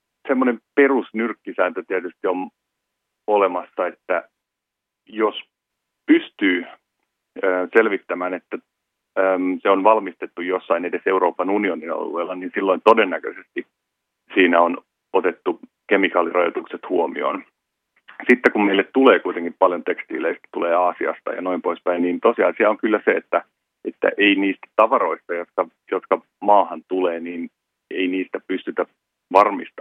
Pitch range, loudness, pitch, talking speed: 90-105 Hz, -20 LUFS, 95 Hz, 115 wpm